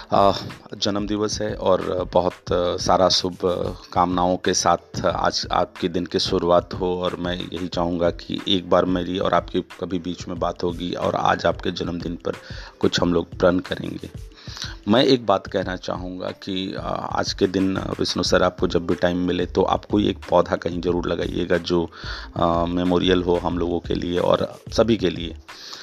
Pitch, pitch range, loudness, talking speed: 90 Hz, 85-95 Hz, -22 LUFS, 170 wpm